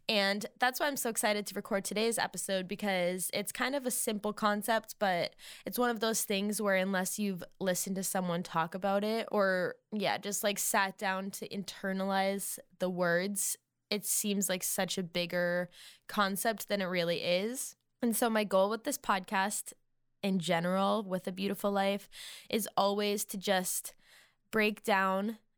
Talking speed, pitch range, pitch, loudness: 170 wpm, 190-215 Hz, 200 Hz, -32 LUFS